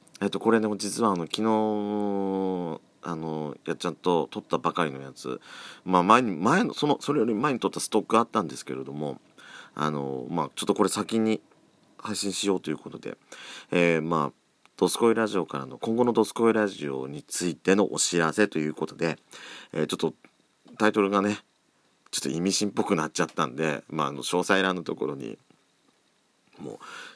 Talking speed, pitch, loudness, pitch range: 360 characters per minute, 95 Hz, -26 LUFS, 80-105 Hz